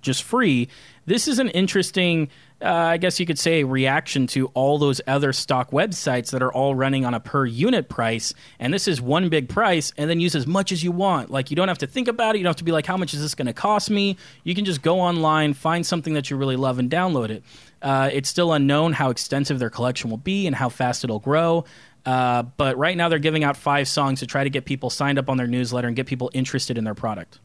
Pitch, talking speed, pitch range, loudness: 140 Hz, 260 wpm, 130-170 Hz, -22 LUFS